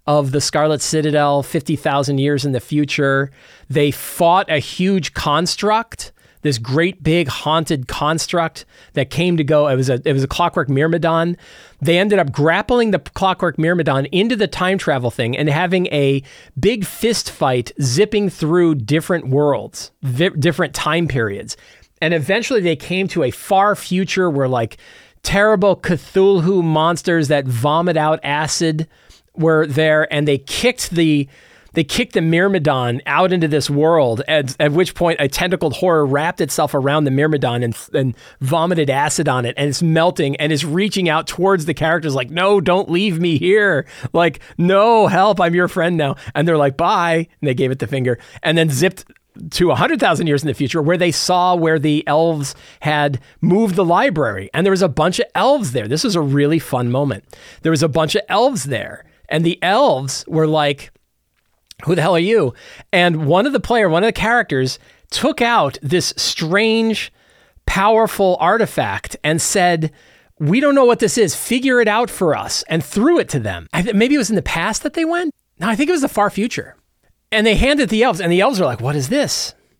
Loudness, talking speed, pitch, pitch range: -16 LUFS, 195 wpm, 165 Hz, 145-190 Hz